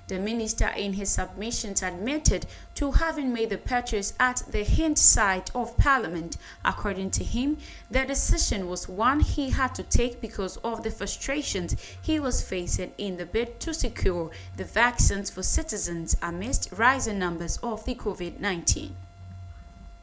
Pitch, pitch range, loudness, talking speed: 205 Hz, 180-245 Hz, -27 LUFS, 155 wpm